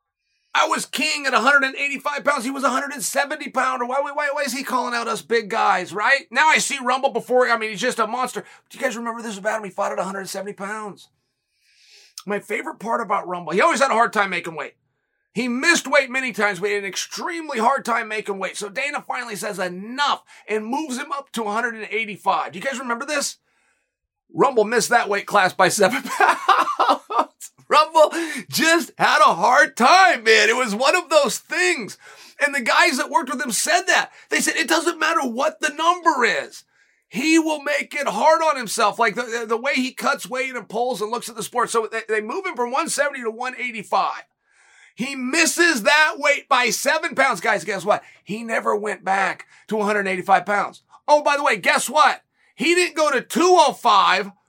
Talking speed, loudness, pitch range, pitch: 200 wpm, -20 LUFS, 215-295 Hz, 255 Hz